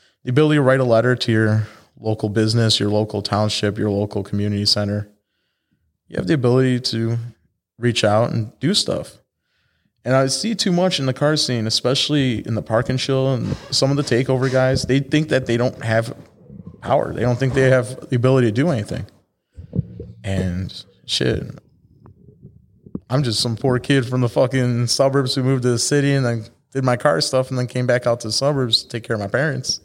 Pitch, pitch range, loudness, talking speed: 125 Hz, 110-135 Hz, -19 LUFS, 200 wpm